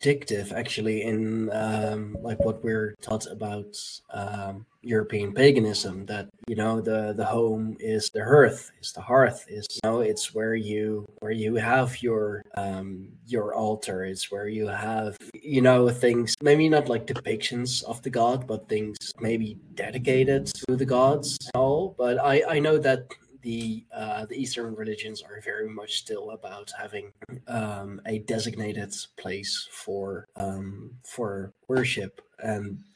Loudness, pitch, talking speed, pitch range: -26 LUFS, 110 Hz, 155 wpm, 105-125 Hz